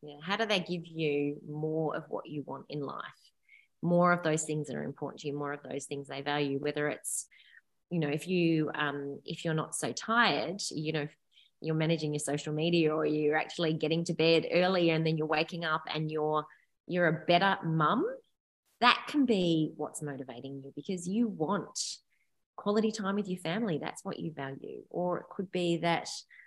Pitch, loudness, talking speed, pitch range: 160 Hz, -32 LUFS, 200 wpm, 150-175 Hz